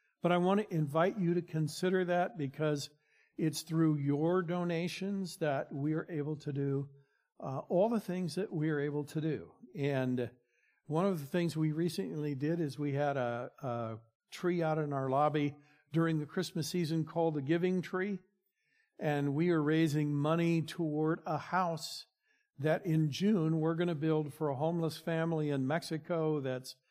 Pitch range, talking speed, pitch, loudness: 145-175 Hz, 175 wpm, 160 Hz, -34 LUFS